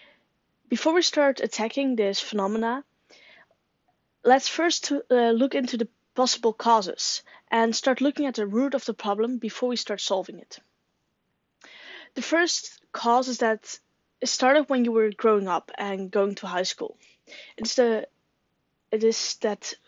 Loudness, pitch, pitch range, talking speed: -25 LUFS, 235 Hz, 220-275 Hz, 150 wpm